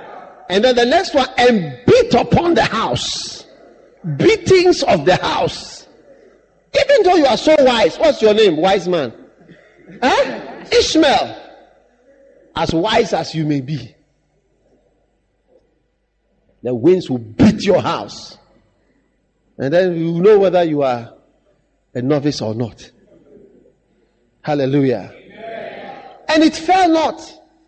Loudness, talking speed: -15 LUFS, 120 wpm